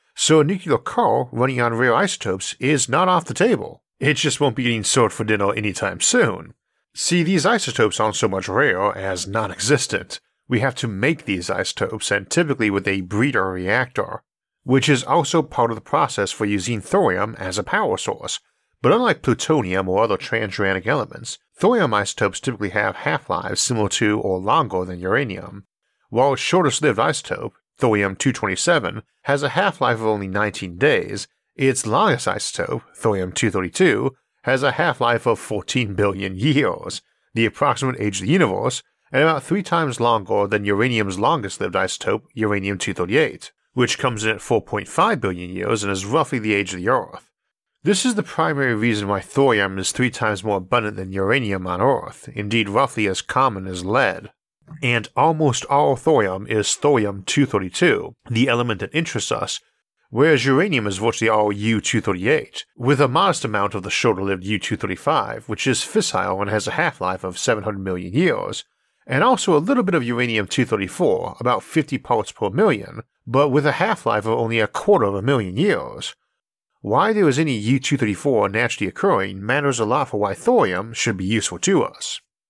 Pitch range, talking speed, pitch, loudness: 100-135 Hz, 180 wpm, 110 Hz, -20 LUFS